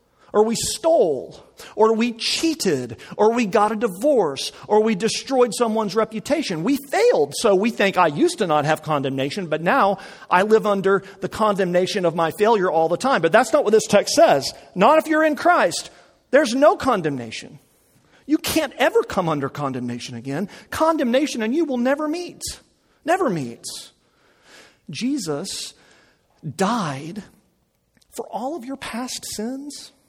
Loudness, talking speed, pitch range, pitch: -20 LUFS, 155 wpm, 180-275 Hz, 220 Hz